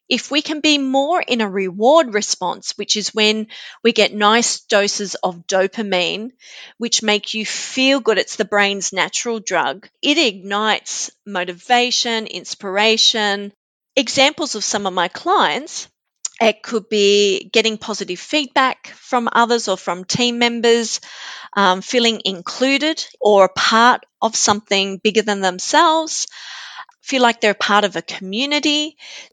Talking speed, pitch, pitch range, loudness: 140 wpm, 215 Hz, 200-245 Hz, -17 LUFS